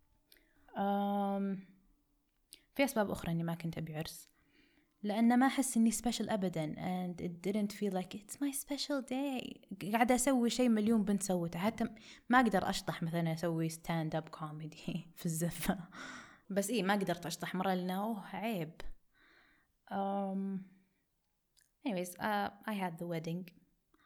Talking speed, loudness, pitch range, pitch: 135 wpm, -36 LUFS, 175-225 Hz, 195 Hz